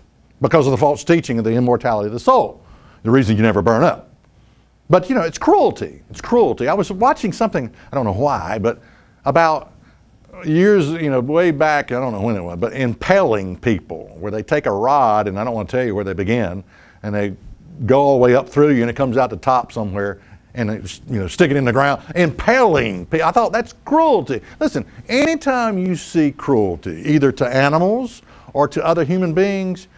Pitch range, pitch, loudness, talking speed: 110-170 Hz, 135 Hz, -17 LUFS, 215 wpm